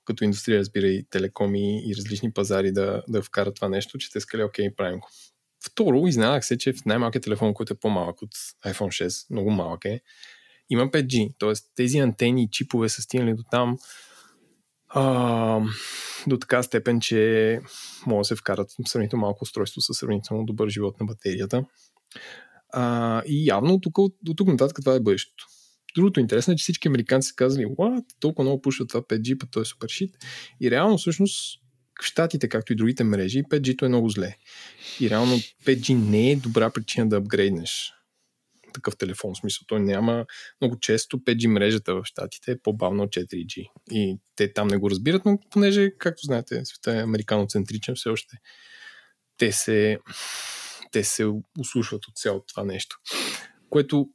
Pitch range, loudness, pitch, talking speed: 105-130 Hz, -24 LUFS, 115 Hz, 175 wpm